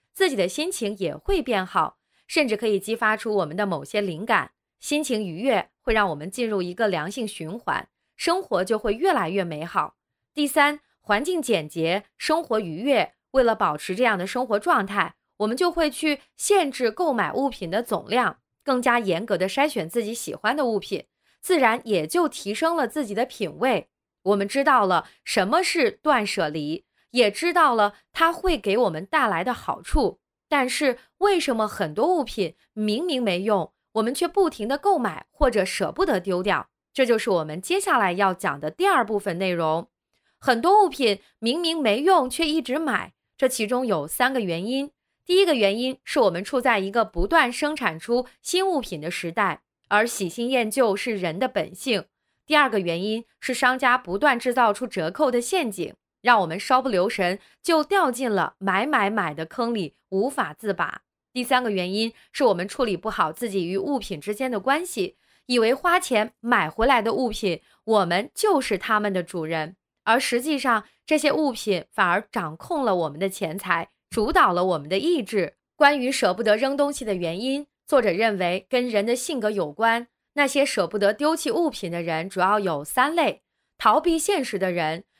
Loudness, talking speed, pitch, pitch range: -23 LUFS, 270 characters per minute, 225 Hz, 195-280 Hz